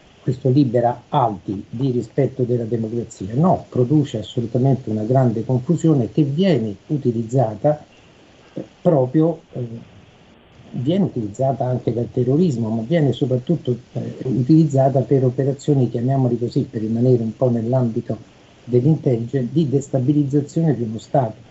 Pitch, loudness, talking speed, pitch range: 130 Hz, -19 LUFS, 120 wpm, 120-145 Hz